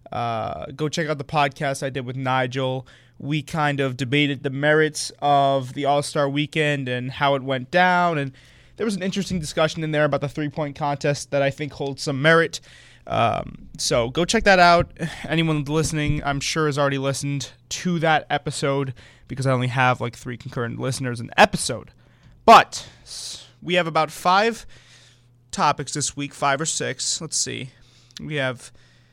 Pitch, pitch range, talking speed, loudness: 140 Hz, 130-155 Hz, 175 wpm, -21 LUFS